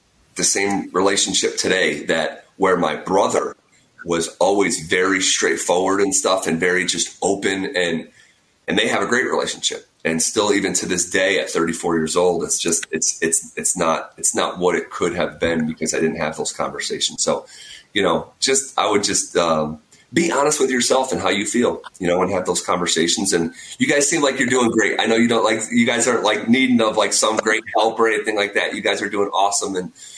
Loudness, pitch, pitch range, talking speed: -18 LUFS, 95 Hz, 80-135 Hz, 215 wpm